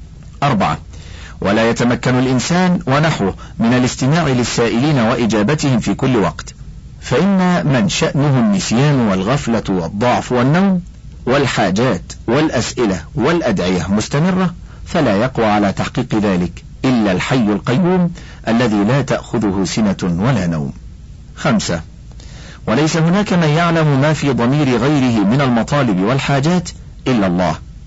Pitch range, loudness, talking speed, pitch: 105-160 Hz, -15 LUFS, 110 wpm, 130 Hz